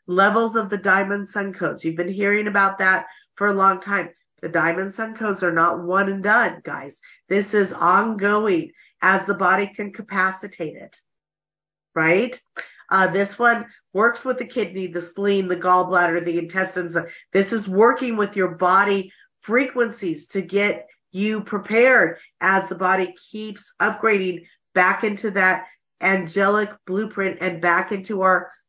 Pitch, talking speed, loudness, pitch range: 195 Hz, 155 wpm, -20 LUFS, 185-210 Hz